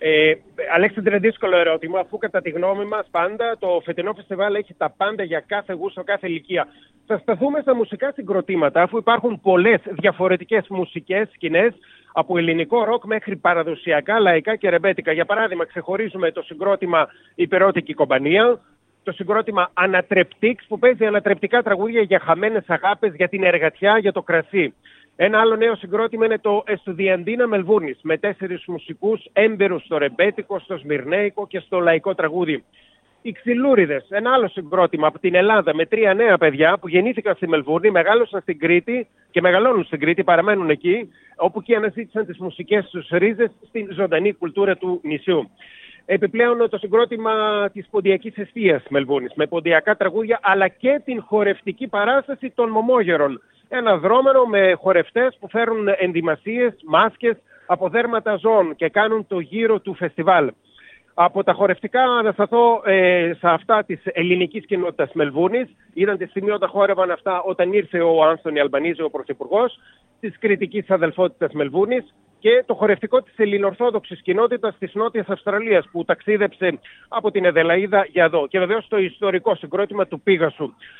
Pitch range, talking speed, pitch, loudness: 175-220 Hz, 155 wpm, 195 Hz, -19 LUFS